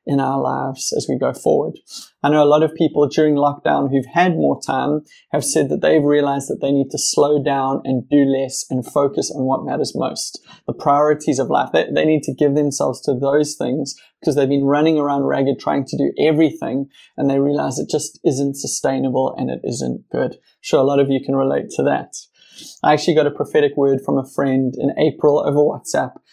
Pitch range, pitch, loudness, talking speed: 135-150 Hz, 140 Hz, -18 LUFS, 220 wpm